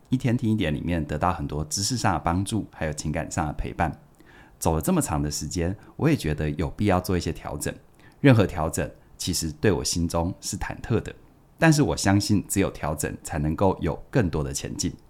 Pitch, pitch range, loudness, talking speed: 85 Hz, 75-105 Hz, -25 LUFS, 305 characters per minute